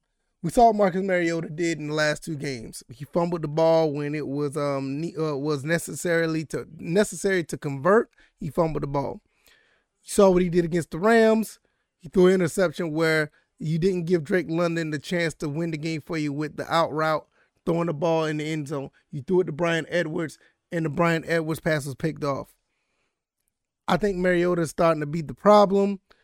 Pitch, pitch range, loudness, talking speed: 165 Hz, 155-180 Hz, -24 LUFS, 205 wpm